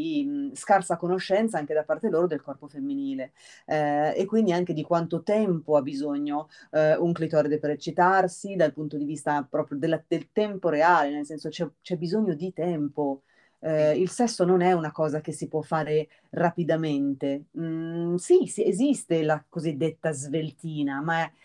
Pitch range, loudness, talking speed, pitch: 150-180 Hz, -26 LUFS, 170 wpm, 160 Hz